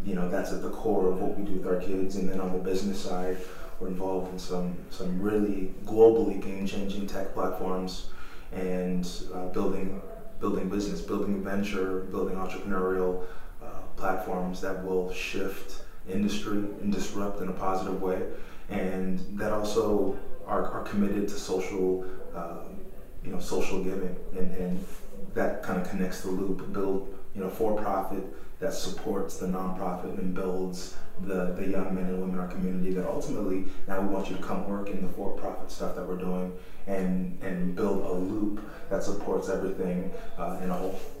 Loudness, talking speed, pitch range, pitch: -31 LUFS, 175 wpm, 90-95 Hz, 95 Hz